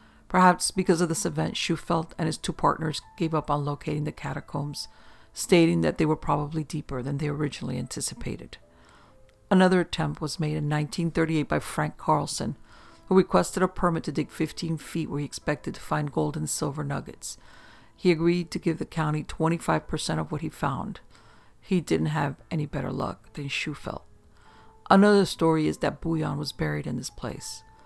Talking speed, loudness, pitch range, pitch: 175 wpm, -27 LUFS, 145-170 Hz, 155 Hz